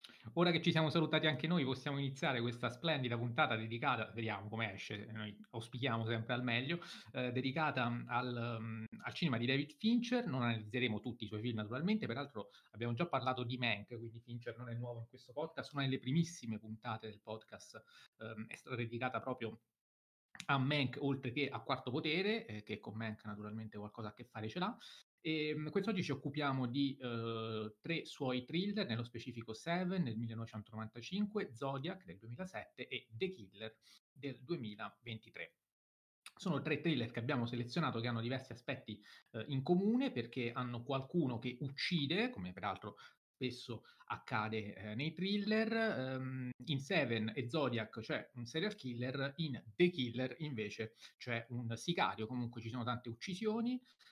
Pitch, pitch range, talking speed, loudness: 125 Hz, 115-150 Hz, 165 wpm, -40 LUFS